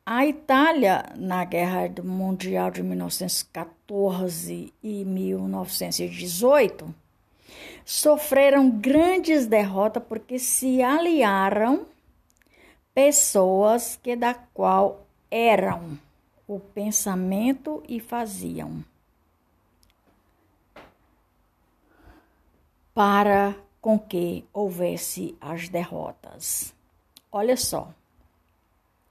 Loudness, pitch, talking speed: -23 LUFS, 195 Hz, 65 wpm